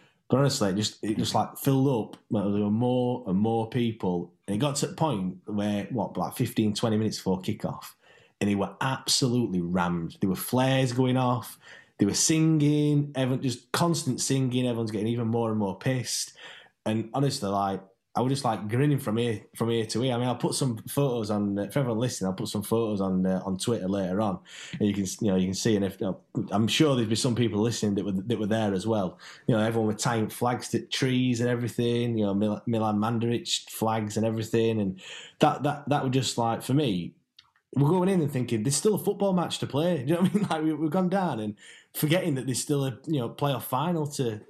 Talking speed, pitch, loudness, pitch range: 230 wpm, 120 Hz, -27 LUFS, 105-140 Hz